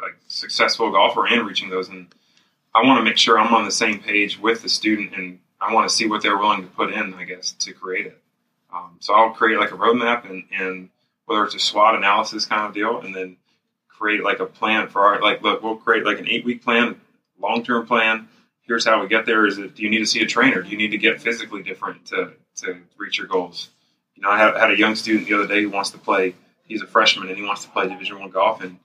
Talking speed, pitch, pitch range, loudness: 260 wpm, 105 Hz, 95-115 Hz, -19 LUFS